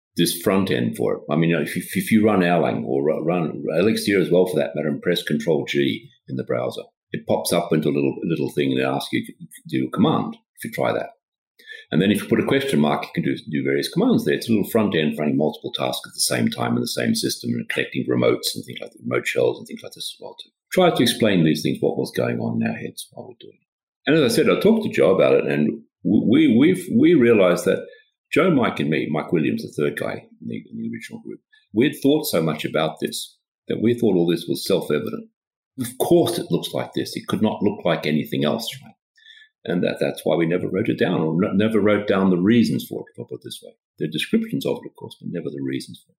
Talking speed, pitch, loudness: 275 wpm, 105 Hz, -21 LUFS